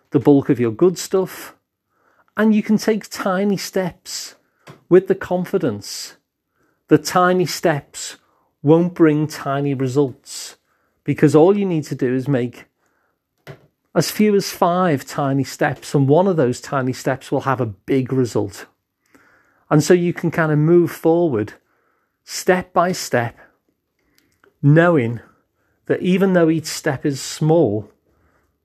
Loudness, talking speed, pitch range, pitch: -18 LUFS, 140 wpm, 135-180 Hz, 155 Hz